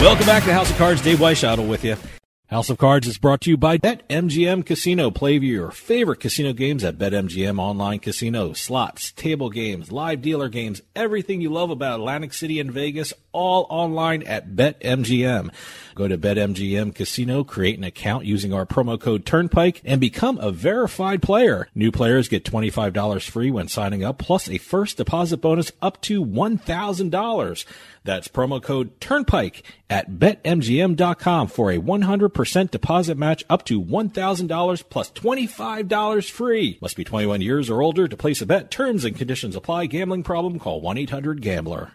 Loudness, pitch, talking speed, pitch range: -21 LUFS, 145 Hz, 165 wpm, 110-175 Hz